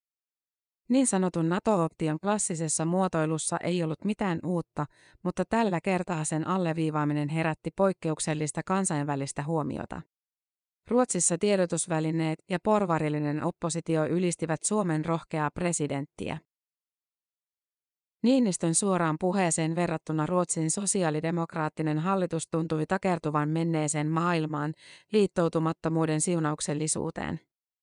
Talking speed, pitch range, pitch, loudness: 85 wpm, 155-185 Hz, 165 Hz, -28 LUFS